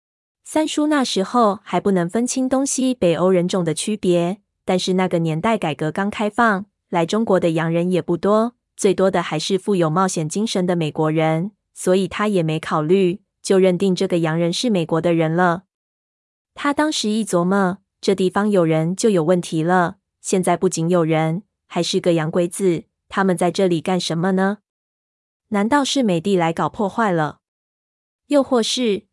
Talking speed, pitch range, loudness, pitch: 255 characters per minute, 170-210 Hz, -19 LUFS, 185 Hz